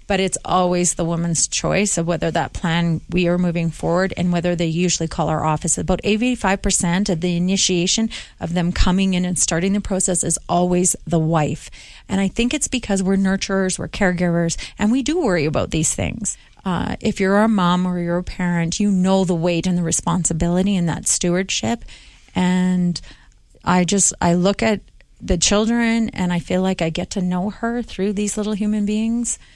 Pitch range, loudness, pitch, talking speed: 170-200 Hz, -19 LUFS, 180 Hz, 195 wpm